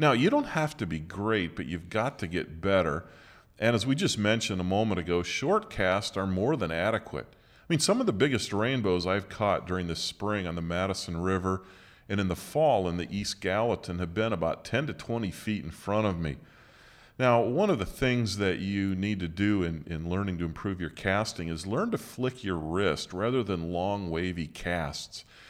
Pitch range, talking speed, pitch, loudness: 90-110 Hz, 210 wpm, 95 Hz, -29 LUFS